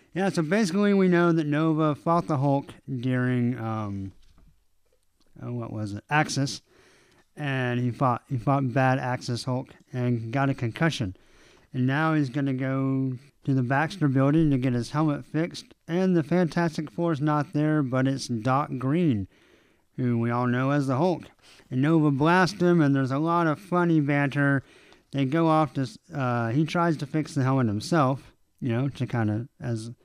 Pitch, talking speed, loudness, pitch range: 135 Hz, 175 wpm, -25 LUFS, 125-155 Hz